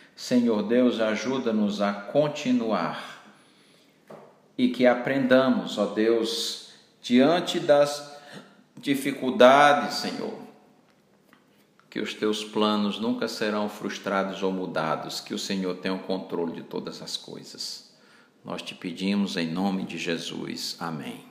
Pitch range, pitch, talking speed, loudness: 100-145 Hz, 115 Hz, 115 wpm, -25 LUFS